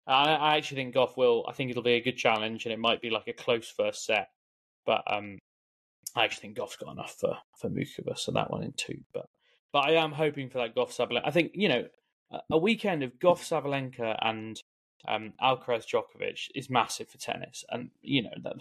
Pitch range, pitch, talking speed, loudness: 110-175 Hz, 135 Hz, 225 wpm, -30 LUFS